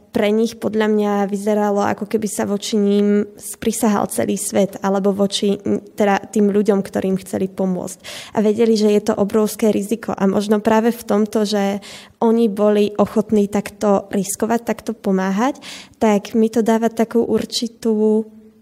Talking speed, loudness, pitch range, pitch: 150 wpm, -18 LUFS, 200-225 Hz, 210 Hz